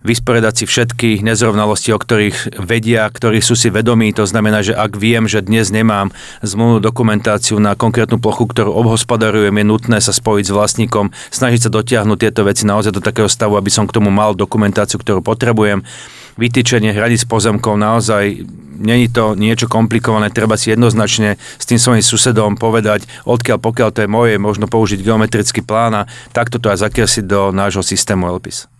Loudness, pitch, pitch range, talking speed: -13 LUFS, 110 Hz, 105-115 Hz, 175 wpm